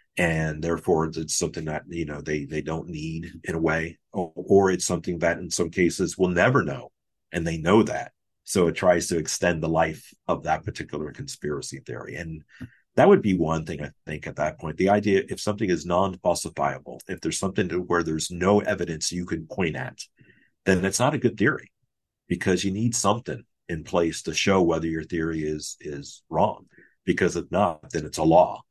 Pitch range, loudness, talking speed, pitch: 80-90 Hz, -25 LUFS, 205 wpm, 85 Hz